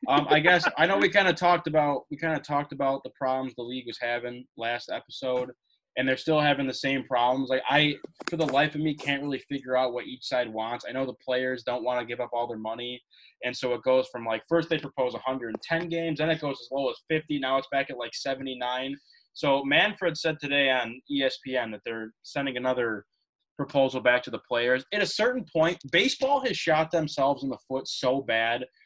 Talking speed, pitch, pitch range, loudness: 225 wpm, 135 Hz, 125-150 Hz, -27 LUFS